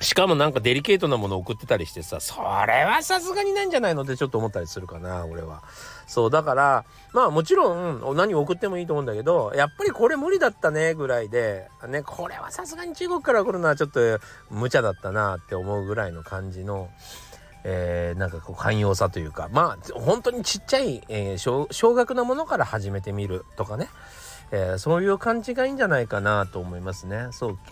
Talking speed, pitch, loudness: 435 characters per minute, 130 Hz, -24 LUFS